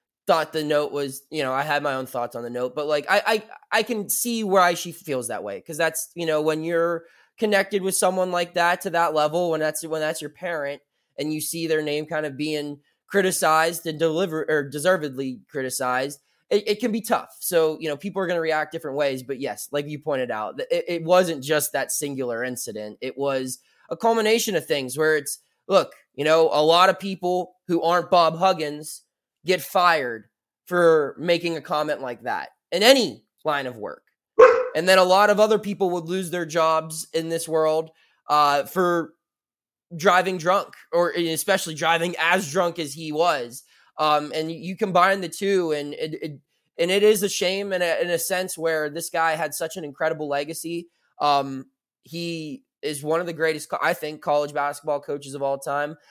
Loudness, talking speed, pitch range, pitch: -23 LUFS, 200 wpm, 150-180 Hz, 160 Hz